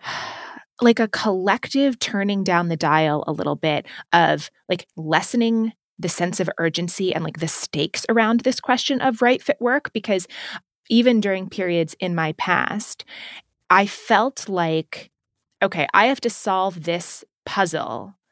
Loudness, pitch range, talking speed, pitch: -21 LUFS, 170-230 Hz, 145 wpm, 190 Hz